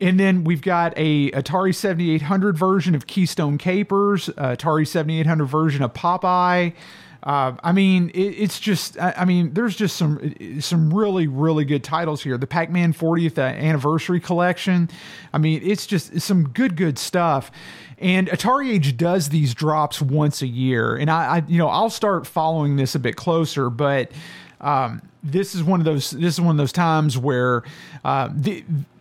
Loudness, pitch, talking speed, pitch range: -20 LUFS, 165 Hz, 175 wpm, 150-180 Hz